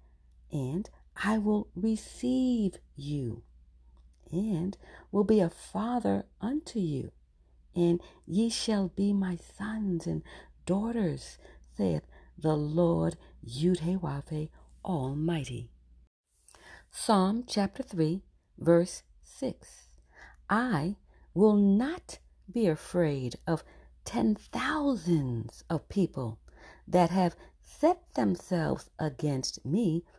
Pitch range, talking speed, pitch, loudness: 125-205 Hz, 90 wpm, 170 Hz, -31 LUFS